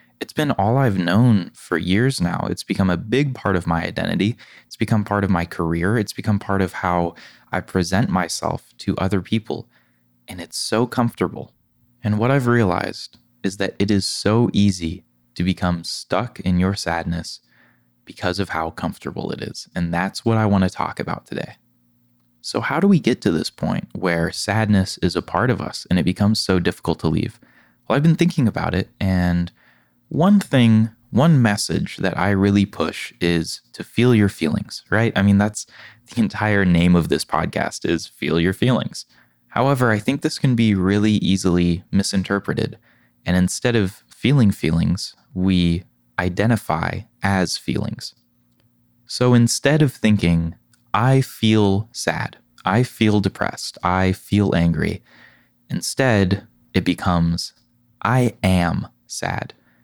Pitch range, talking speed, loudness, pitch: 85-115 Hz, 160 wpm, -20 LUFS, 100 Hz